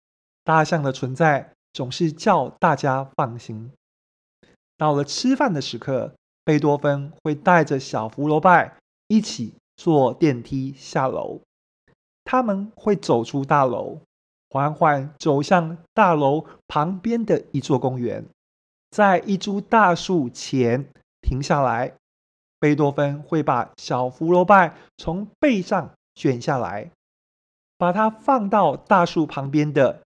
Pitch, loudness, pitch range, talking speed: 150 Hz, -21 LUFS, 135-180 Hz, 180 characters per minute